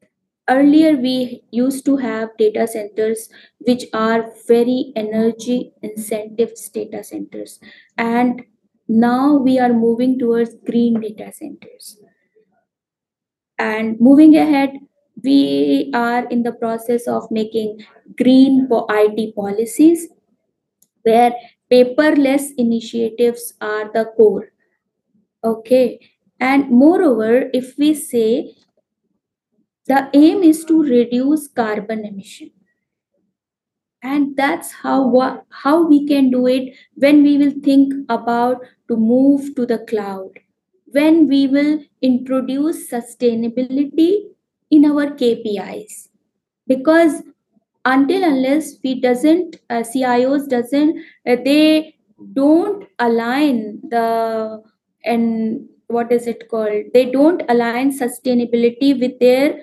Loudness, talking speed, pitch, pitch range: -16 LUFS, 110 wpm, 245 Hz, 225-280 Hz